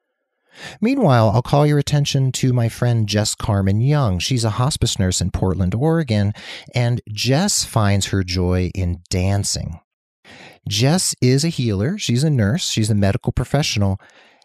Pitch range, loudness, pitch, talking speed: 100-135 Hz, -18 LUFS, 115 Hz, 150 wpm